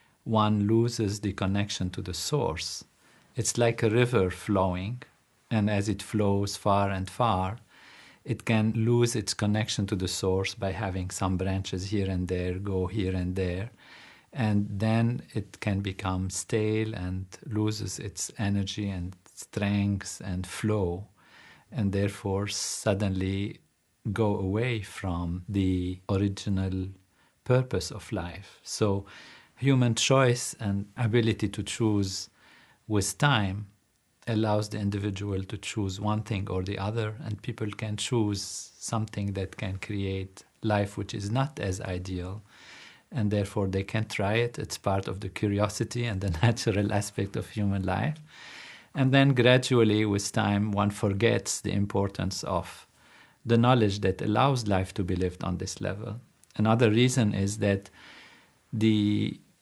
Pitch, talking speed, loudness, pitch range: 105 Hz, 140 wpm, -28 LUFS, 95-110 Hz